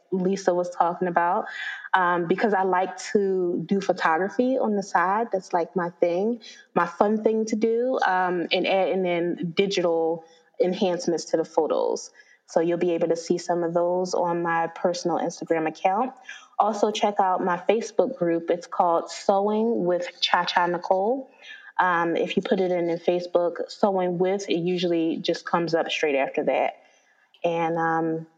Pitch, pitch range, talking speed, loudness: 180 Hz, 170-215 Hz, 165 wpm, -24 LUFS